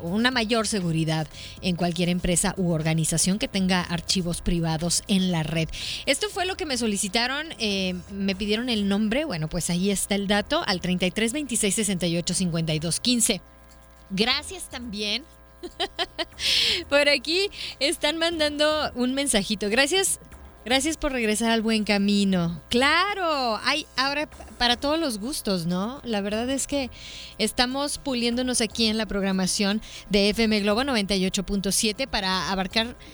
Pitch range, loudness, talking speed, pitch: 185-270 Hz, -24 LUFS, 135 wpm, 215 Hz